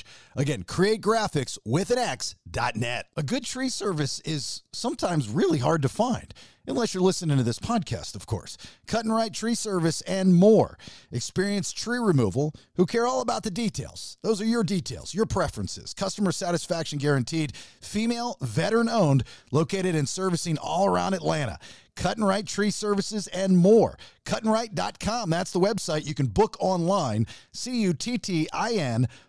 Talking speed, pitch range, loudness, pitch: 150 wpm, 150-220 Hz, -26 LUFS, 185 Hz